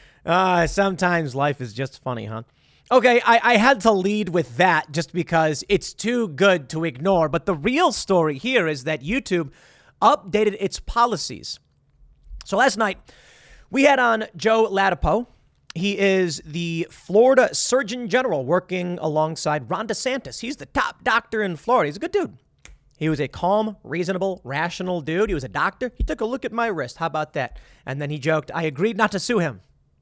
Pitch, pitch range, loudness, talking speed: 185 Hz, 155-225 Hz, -21 LUFS, 185 wpm